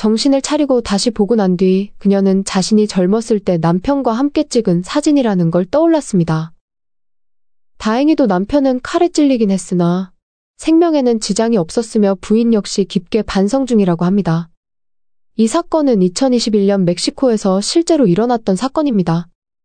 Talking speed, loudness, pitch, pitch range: 320 characters per minute, -14 LUFS, 215 Hz, 190-265 Hz